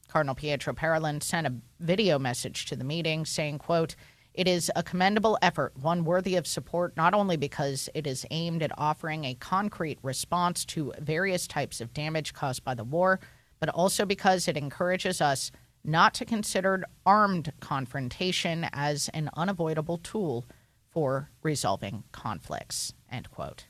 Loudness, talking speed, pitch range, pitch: -29 LUFS, 155 wpm, 135-180 Hz, 155 Hz